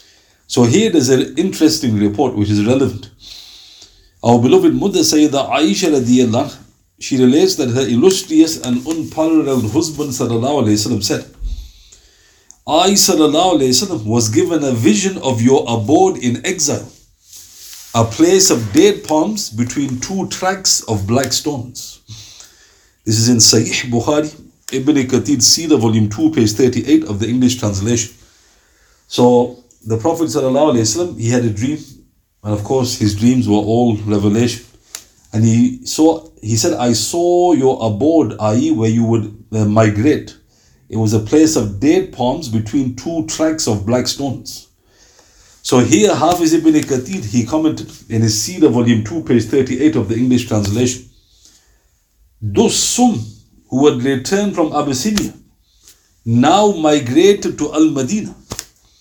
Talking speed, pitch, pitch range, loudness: 135 wpm, 120 Hz, 110-150 Hz, -14 LUFS